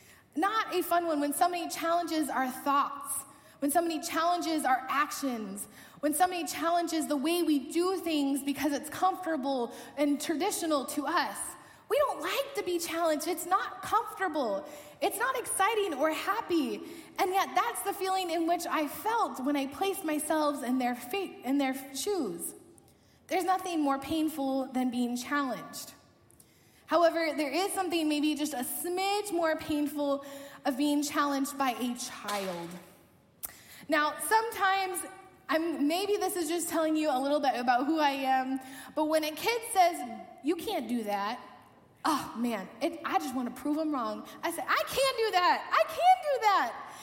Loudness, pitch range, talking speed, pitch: -30 LUFS, 275-360 Hz, 165 wpm, 315 Hz